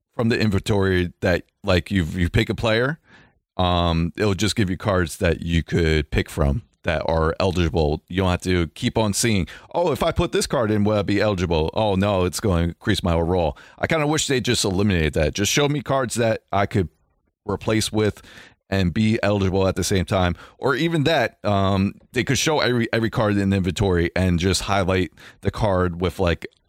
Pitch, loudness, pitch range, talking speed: 95 Hz, -21 LUFS, 85-110 Hz, 210 wpm